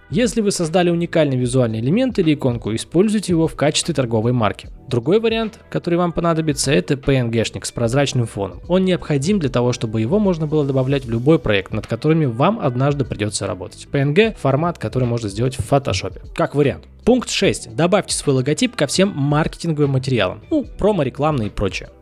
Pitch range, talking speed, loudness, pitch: 115-170 Hz, 175 wpm, -18 LUFS, 140 Hz